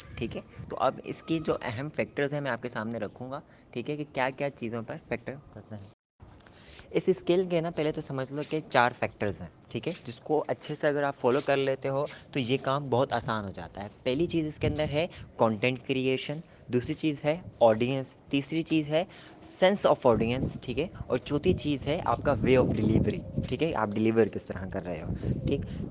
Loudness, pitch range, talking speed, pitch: -29 LUFS, 115-150 Hz, 225 wpm, 135 Hz